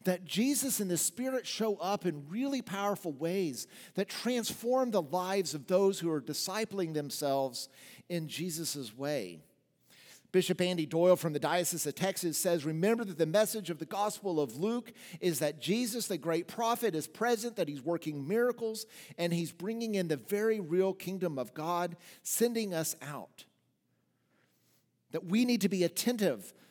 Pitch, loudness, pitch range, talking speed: 180 Hz, -33 LUFS, 160-215 Hz, 165 wpm